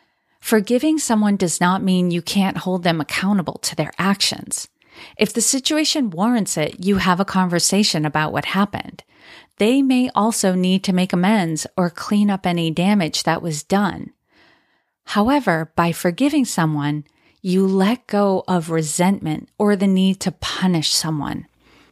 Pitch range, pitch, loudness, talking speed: 170-210 Hz, 190 Hz, -19 LUFS, 150 wpm